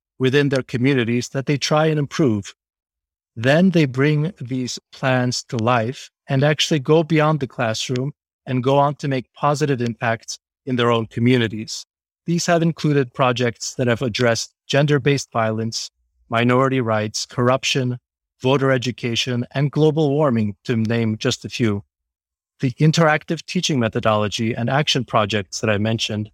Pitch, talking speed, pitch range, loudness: 125 Hz, 150 wpm, 115-145 Hz, -20 LUFS